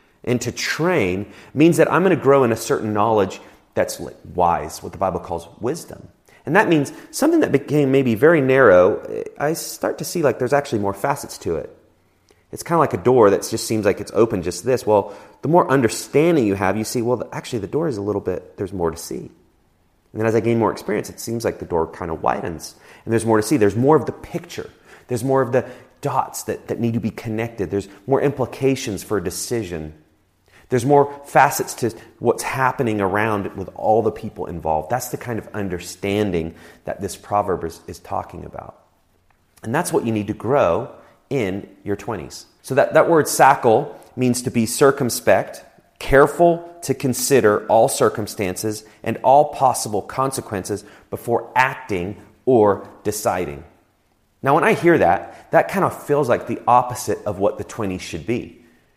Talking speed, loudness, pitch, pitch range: 190 wpm, -19 LUFS, 115 Hz, 100-135 Hz